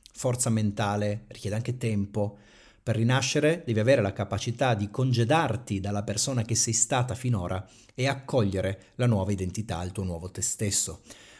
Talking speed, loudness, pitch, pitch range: 155 wpm, -27 LUFS, 110 Hz, 100-125 Hz